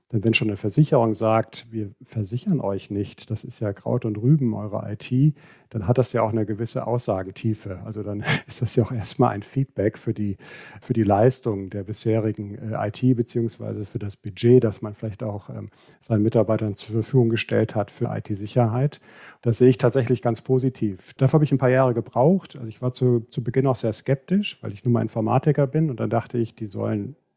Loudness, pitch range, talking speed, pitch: -23 LUFS, 110-125 Hz, 205 wpm, 115 Hz